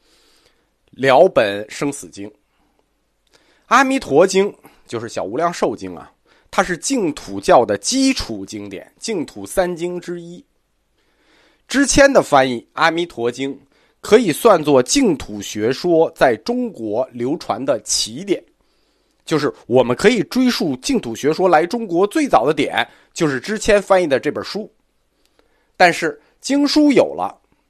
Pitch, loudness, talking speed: 175 Hz, -17 LUFS, 200 characters per minute